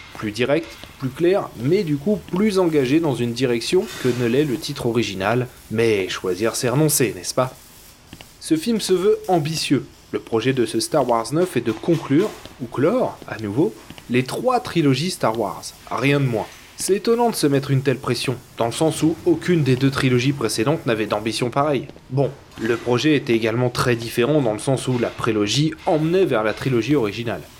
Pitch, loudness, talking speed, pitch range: 135 Hz, -20 LUFS, 195 wpm, 115-160 Hz